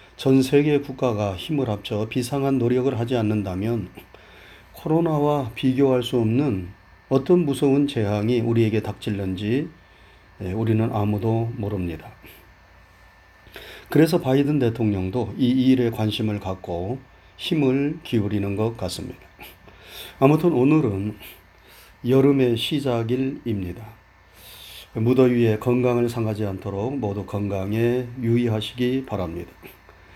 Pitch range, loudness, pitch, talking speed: 100-130 Hz, -22 LUFS, 115 Hz, 255 characters per minute